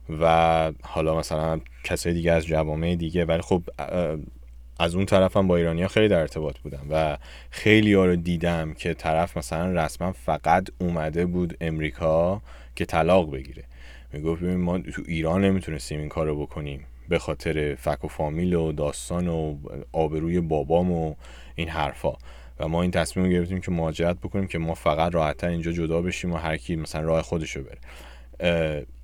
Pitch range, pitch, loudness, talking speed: 75-85 Hz, 80 Hz, -25 LUFS, 165 wpm